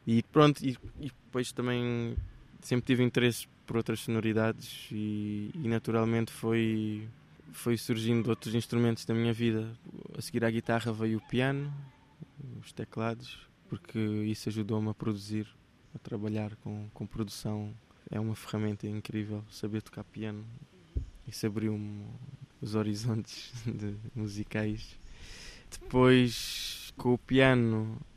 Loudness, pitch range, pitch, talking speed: -32 LUFS, 105-125 Hz, 115 Hz, 130 wpm